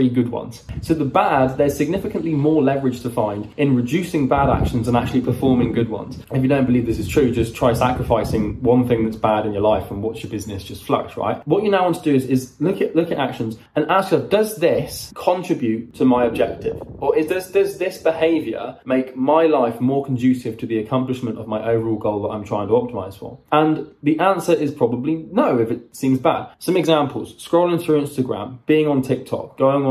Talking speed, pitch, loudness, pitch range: 220 wpm, 130 Hz, -19 LUFS, 115-155 Hz